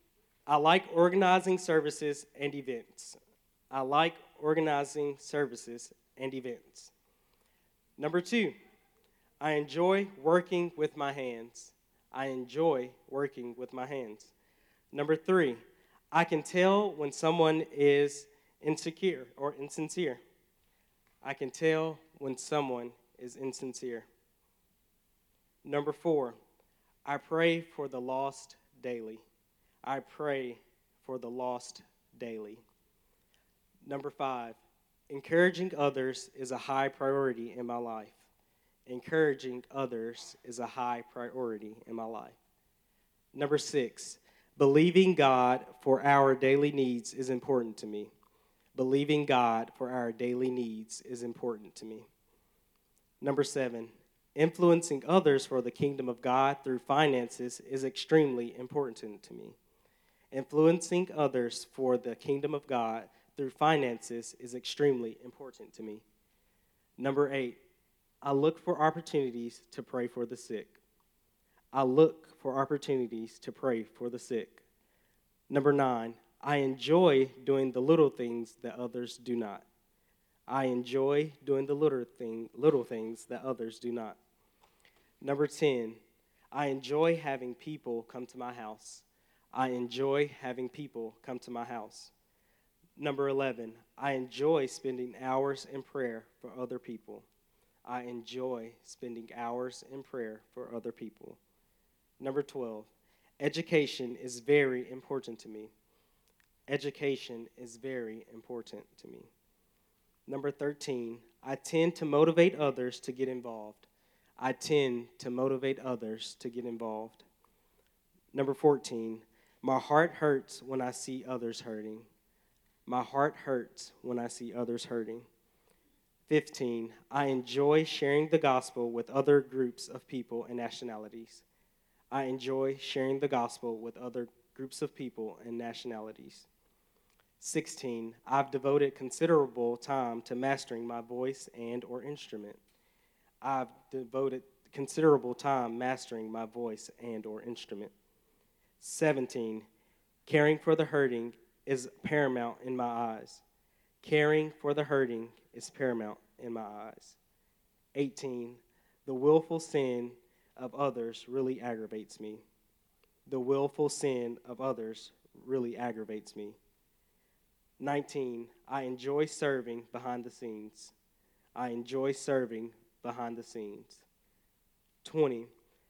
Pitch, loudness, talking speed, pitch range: 130 Hz, -33 LUFS, 120 wpm, 120-145 Hz